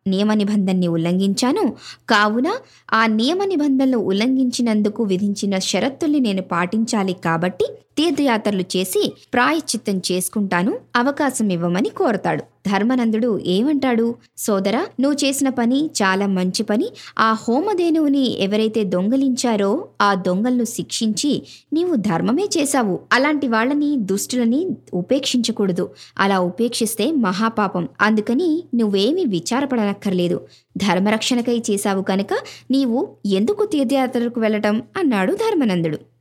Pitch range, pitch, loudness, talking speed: 195-265 Hz, 225 Hz, -19 LUFS, 95 wpm